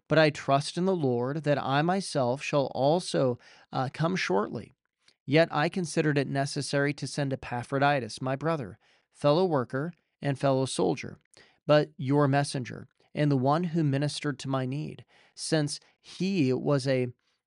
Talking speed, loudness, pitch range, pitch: 150 wpm, -28 LUFS, 135-155 Hz, 145 Hz